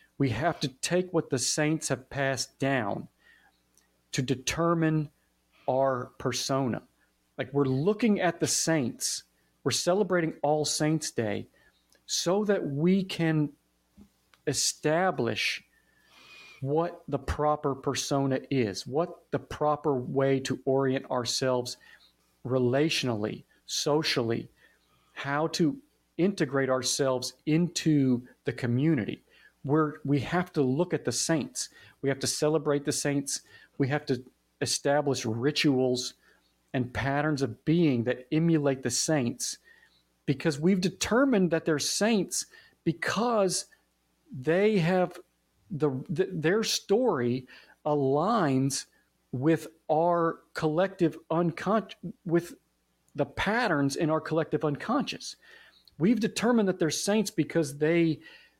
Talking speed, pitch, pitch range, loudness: 115 wpm, 145 Hz, 130-165 Hz, -28 LUFS